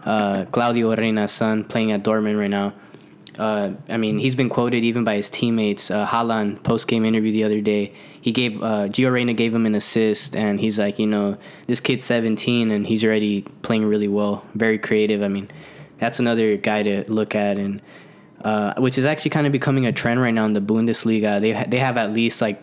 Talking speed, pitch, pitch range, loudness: 215 wpm, 110 Hz, 105-120 Hz, -20 LUFS